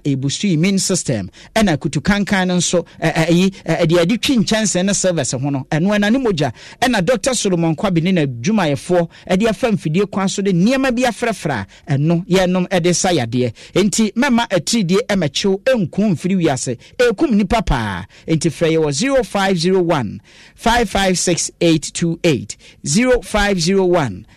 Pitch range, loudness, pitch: 165-210 Hz, -16 LUFS, 185 Hz